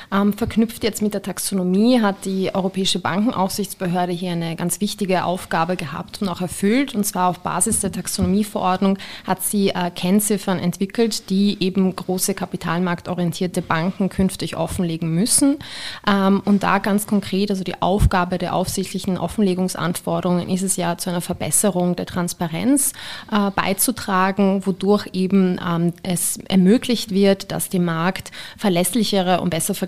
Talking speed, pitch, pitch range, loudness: 135 wpm, 190 Hz, 180-205 Hz, -20 LUFS